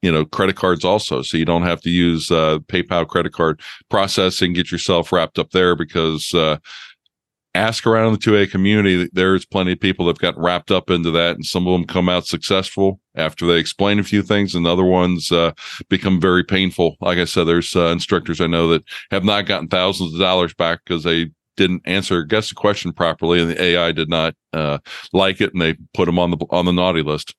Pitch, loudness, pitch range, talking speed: 90 Hz, -17 LUFS, 85-95 Hz, 225 wpm